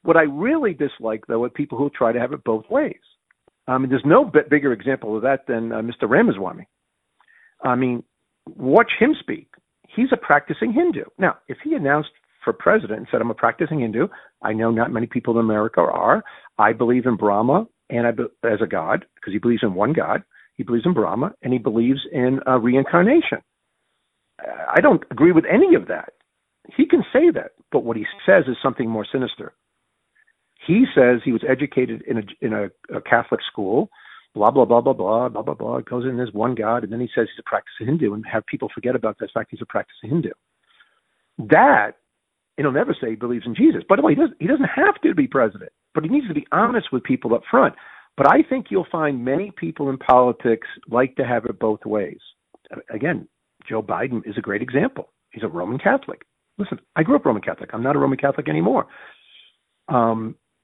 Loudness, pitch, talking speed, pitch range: -20 LUFS, 130 Hz, 210 wpm, 120-175 Hz